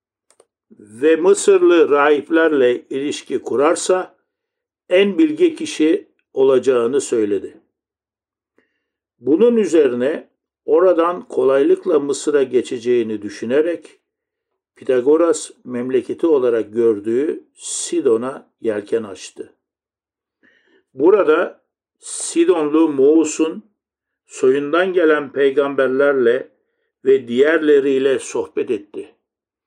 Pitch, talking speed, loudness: 370 Hz, 70 wpm, -17 LUFS